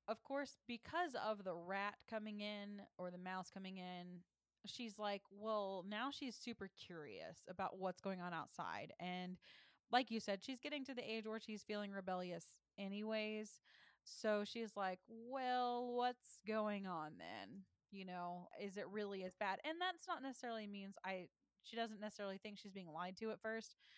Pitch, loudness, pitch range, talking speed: 210 Hz, -47 LUFS, 190-230 Hz, 175 wpm